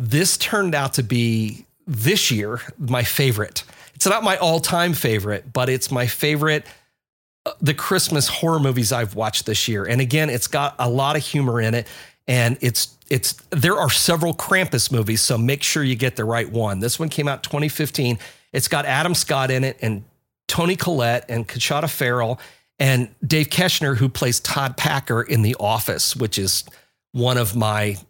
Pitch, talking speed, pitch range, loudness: 130 Hz, 185 wpm, 115-150 Hz, -20 LUFS